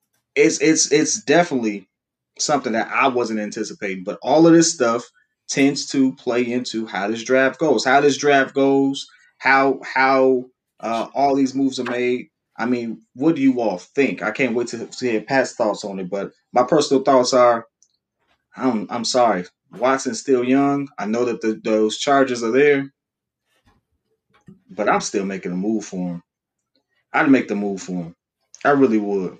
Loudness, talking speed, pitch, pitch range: -19 LUFS, 180 wpm, 125 Hz, 110-135 Hz